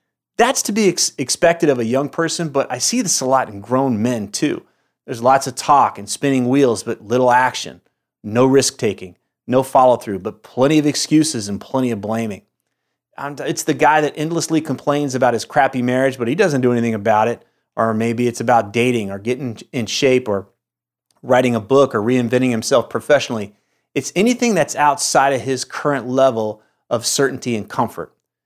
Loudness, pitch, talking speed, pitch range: -17 LUFS, 130 Hz, 190 wpm, 115-140 Hz